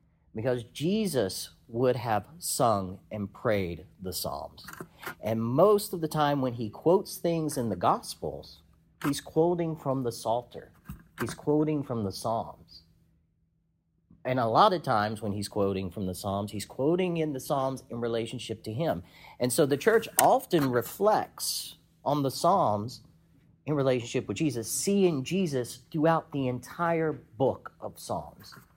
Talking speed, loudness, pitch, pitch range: 150 wpm, -29 LUFS, 130 Hz, 110-155 Hz